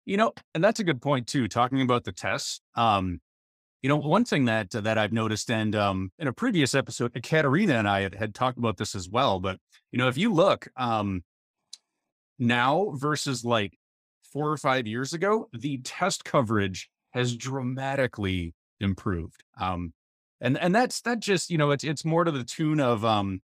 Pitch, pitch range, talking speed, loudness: 120 Hz, 100-145 Hz, 190 wpm, -26 LUFS